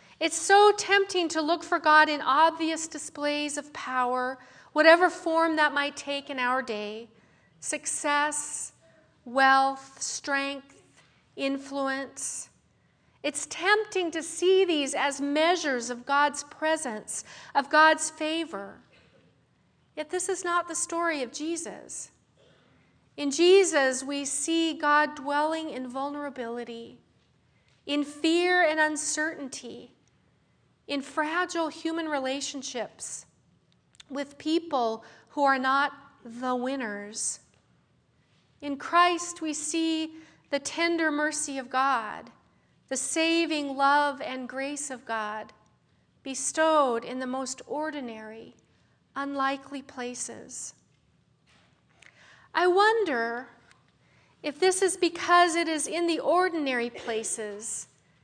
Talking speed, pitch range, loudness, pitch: 105 wpm, 270-325 Hz, -27 LUFS, 290 Hz